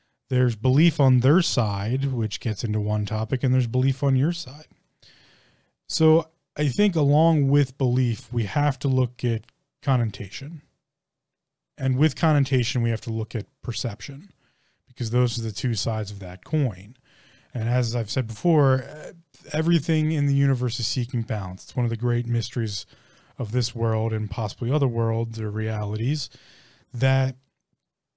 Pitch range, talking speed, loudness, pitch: 115-140 Hz, 160 wpm, -24 LUFS, 125 Hz